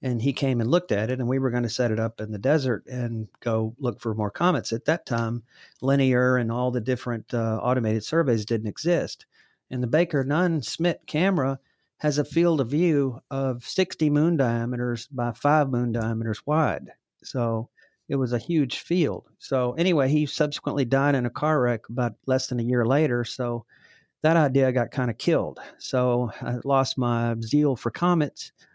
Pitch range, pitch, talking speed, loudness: 120-145 Hz, 125 Hz, 190 wpm, -25 LUFS